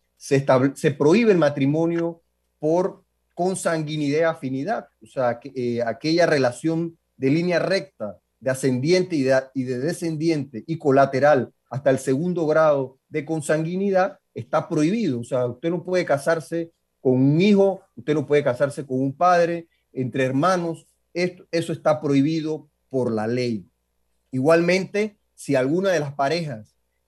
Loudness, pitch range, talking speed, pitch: -22 LUFS, 130-165 Hz, 145 wpm, 150 Hz